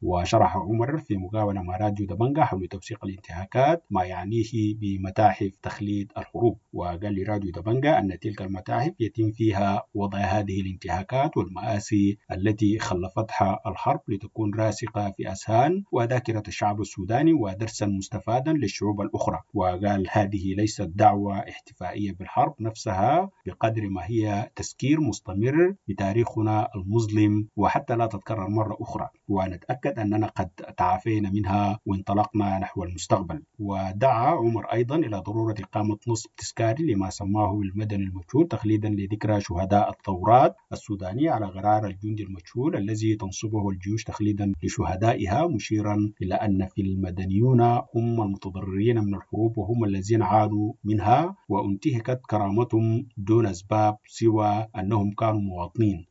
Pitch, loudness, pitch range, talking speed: 105 Hz, -25 LUFS, 100-115 Hz, 125 wpm